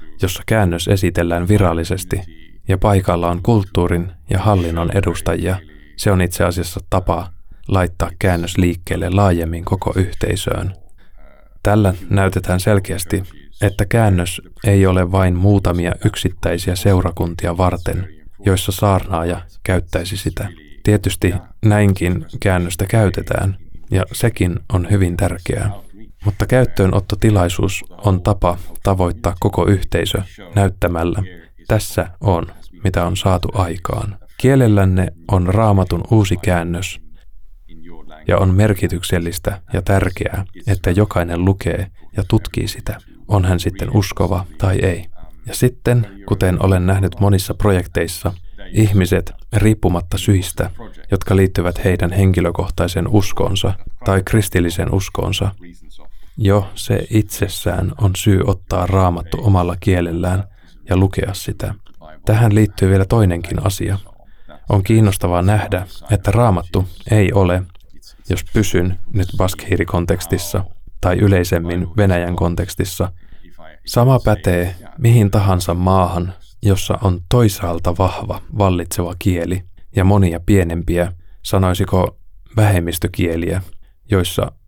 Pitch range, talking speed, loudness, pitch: 85-100 Hz, 105 wpm, -17 LUFS, 95 Hz